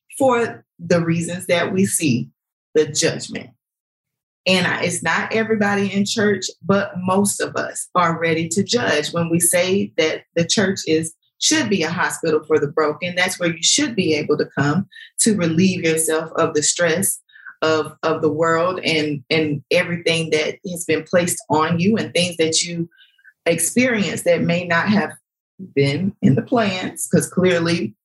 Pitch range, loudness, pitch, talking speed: 160-195 Hz, -19 LUFS, 170 Hz, 170 wpm